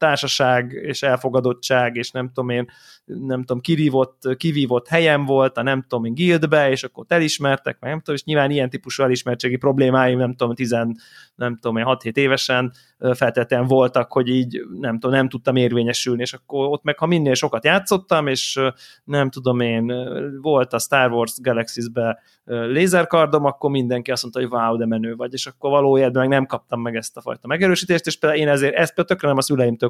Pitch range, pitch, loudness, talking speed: 125-145 Hz, 130 Hz, -19 LUFS, 185 wpm